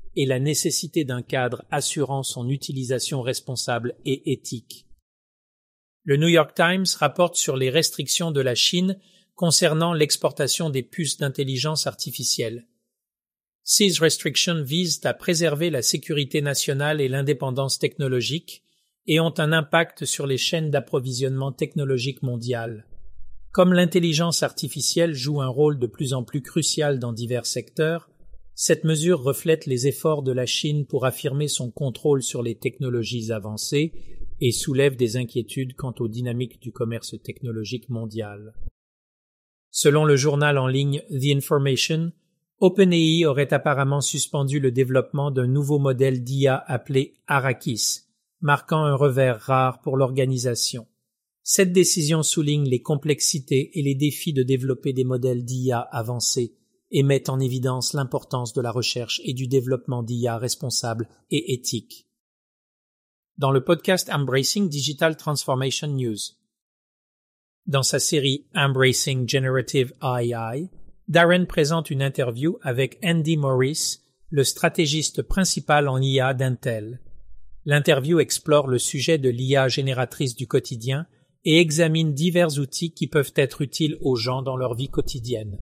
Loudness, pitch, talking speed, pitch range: -22 LUFS, 140 Hz, 135 wpm, 125-155 Hz